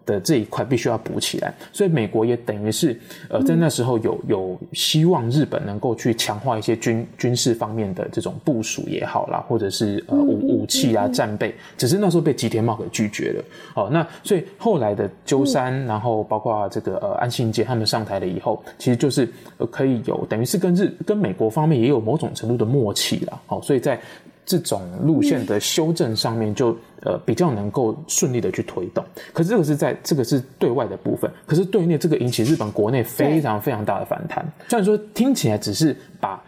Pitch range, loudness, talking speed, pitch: 110-165 Hz, -21 LUFS, 320 characters per minute, 130 Hz